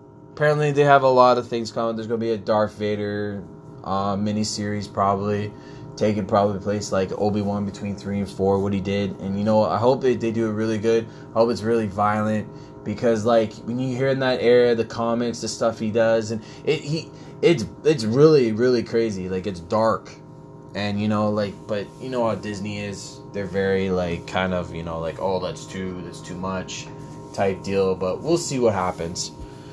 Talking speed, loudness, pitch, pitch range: 205 wpm, -22 LUFS, 105 Hz, 100-120 Hz